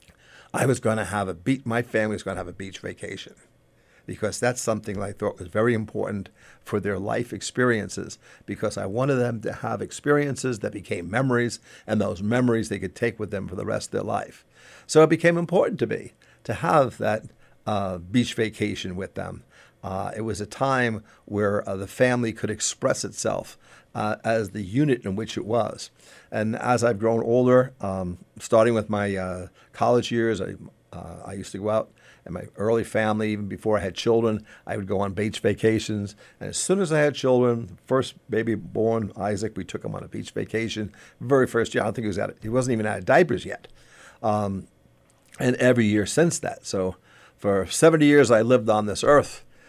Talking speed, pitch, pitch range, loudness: 205 wpm, 110 Hz, 100-120 Hz, -24 LUFS